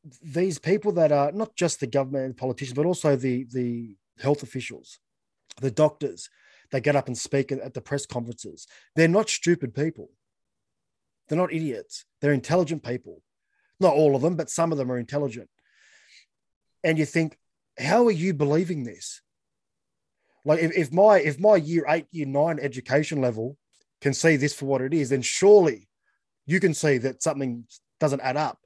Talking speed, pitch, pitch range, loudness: 175 wpm, 145 Hz, 135-165 Hz, -24 LUFS